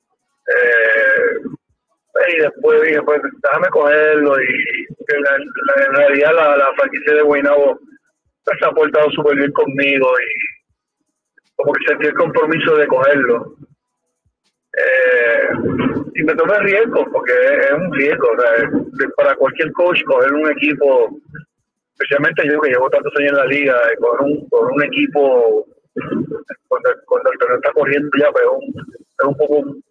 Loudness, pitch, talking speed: -14 LUFS, 275 Hz, 155 wpm